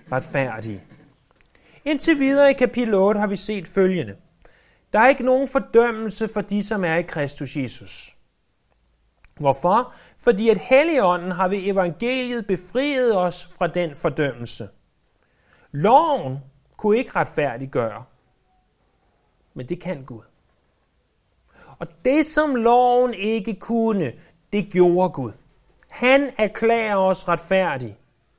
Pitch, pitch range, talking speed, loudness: 185 Hz, 140-230 Hz, 115 wpm, -21 LUFS